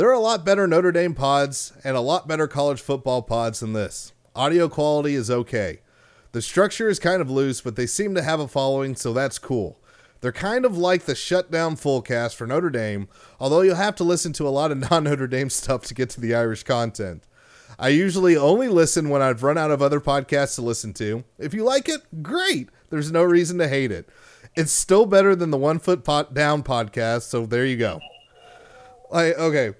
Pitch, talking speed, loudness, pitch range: 145 Hz, 220 wpm, -21 LUFS, 125-175 Hz